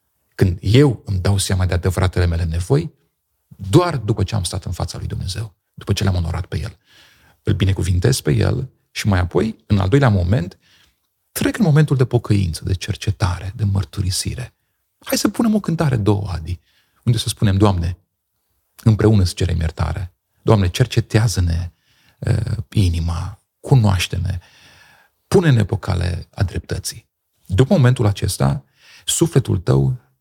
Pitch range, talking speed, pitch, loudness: 90-115 Hz, 145 wpm, 100 Hz, -19 LUFS